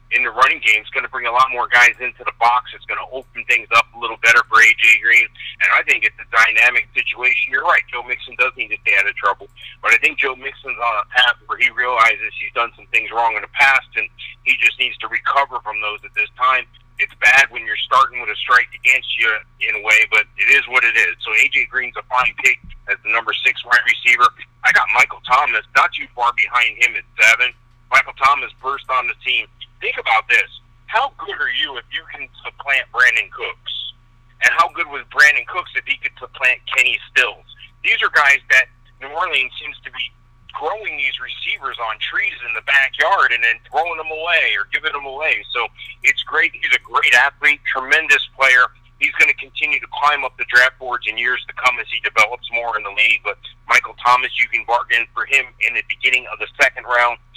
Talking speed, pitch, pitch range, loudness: 230 wpm, 125 Hz, 120-150 Hz, -15 LUFS